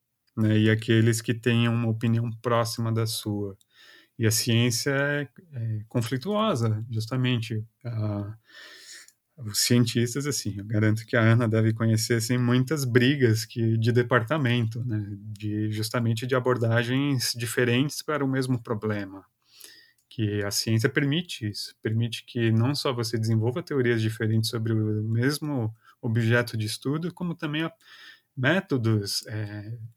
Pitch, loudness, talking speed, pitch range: 115 Hz, -26 LUFS, 135 wpm, 110-130 Hz